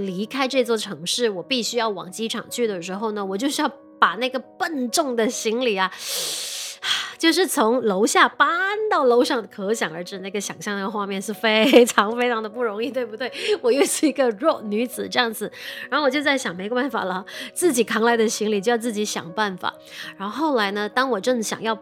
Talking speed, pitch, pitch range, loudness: 300 characters per minute, 230 Hz, 210-260 Hz, -22 LUFS